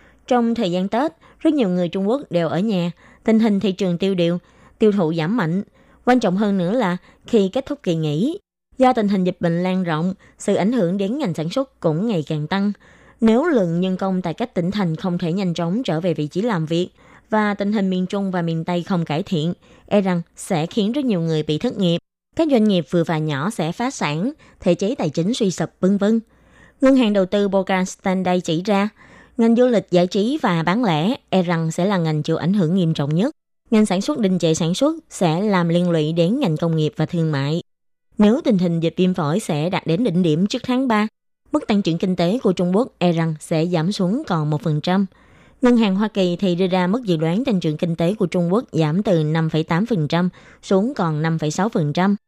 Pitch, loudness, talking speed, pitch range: 185 Hz, -20 LUFS, 235 wpm, 170-215 Hz